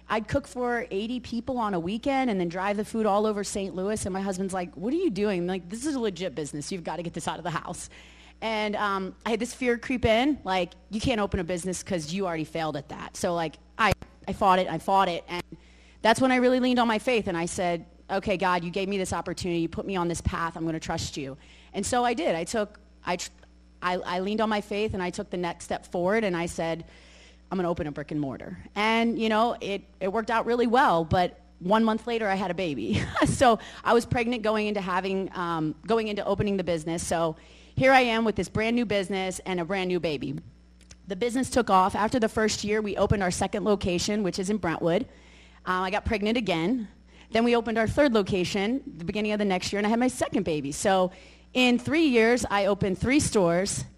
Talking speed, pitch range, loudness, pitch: 250 wpm, 175-225 Hz, -27 LUFS, 195 Hz